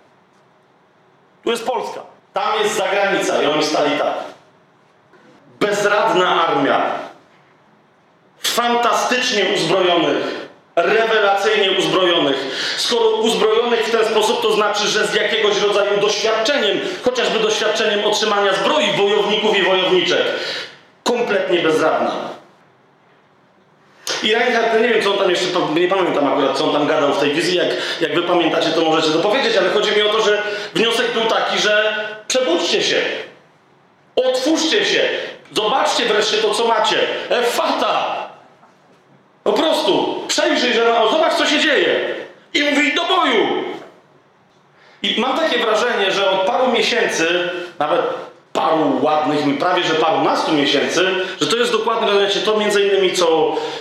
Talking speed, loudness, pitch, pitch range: 135 wpm, -16 LUFS, 215 Hz, 195-250 Hz